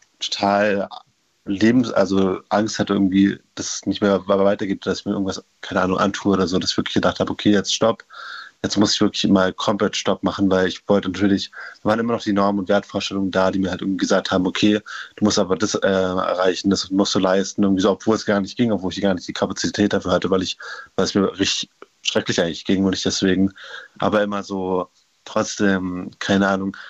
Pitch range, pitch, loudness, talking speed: 95-100 Hz, 100 Hz, -20 LUFS, 220 wpm